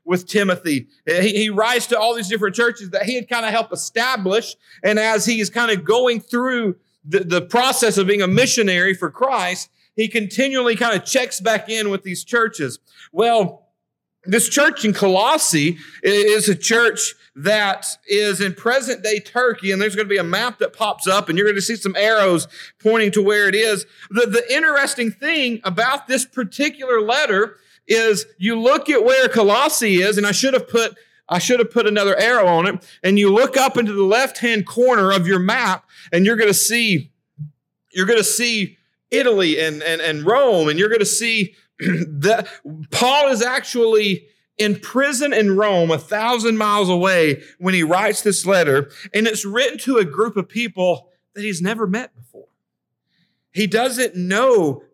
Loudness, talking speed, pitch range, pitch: -17 LUFS, 180 wpm, 190-235 Hz, 210 Hz